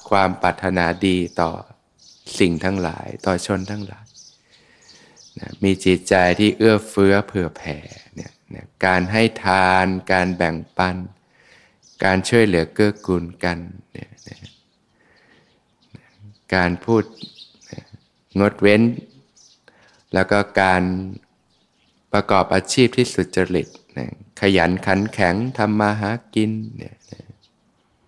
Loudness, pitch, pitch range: -19 LUFS, 95 Hz, 90-105 Hz